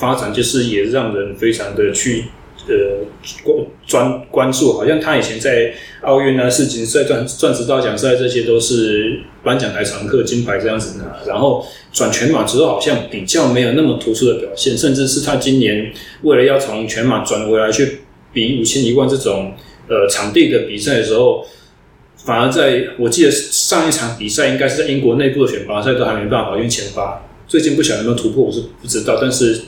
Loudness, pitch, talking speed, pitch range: -15 LUFS, 125 Hz, 300 characters per minute, 110-155 Hz